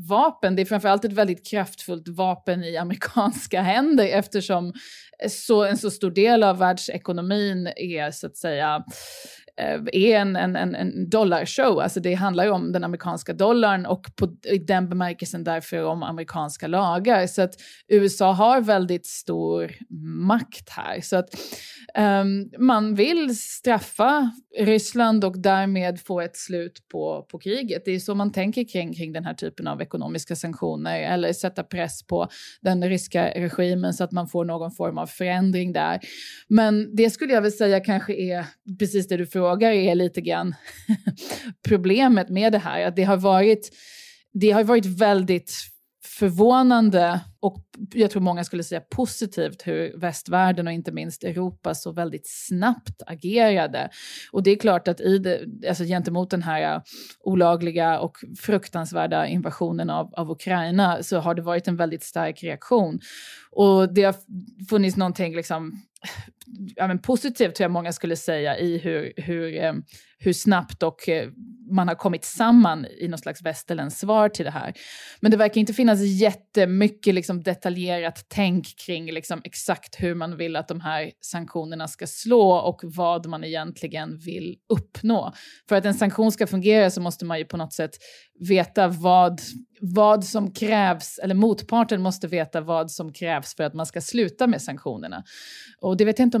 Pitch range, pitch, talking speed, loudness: 170-210 Hz, 185 Hz, 165 wpm, -23 LUFS